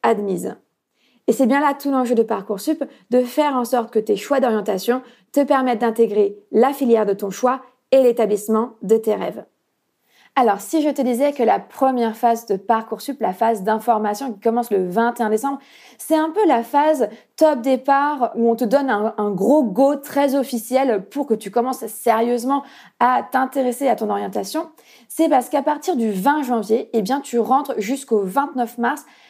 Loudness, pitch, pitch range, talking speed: -19 LUFS, 245 Hz, 225-275 Hz, 185 wpm